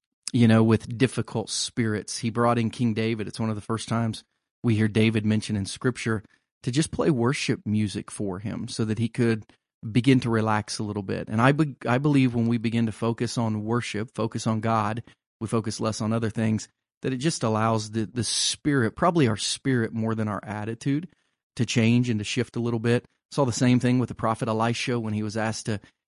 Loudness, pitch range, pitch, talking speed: -25 LUFS, 110-125 Hz, 115 Hz, 220 wpm